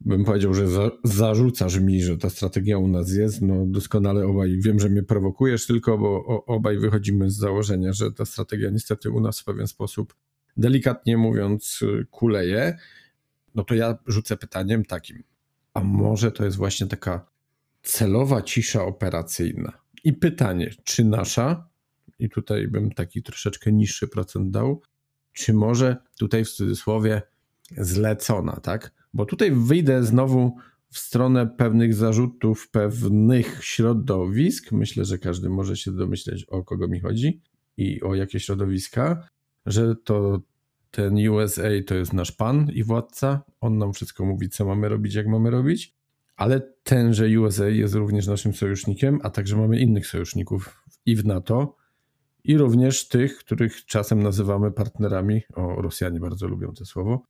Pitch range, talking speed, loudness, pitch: 100-125 Hz, 150 wpm, -23 LUFS, 110 Hz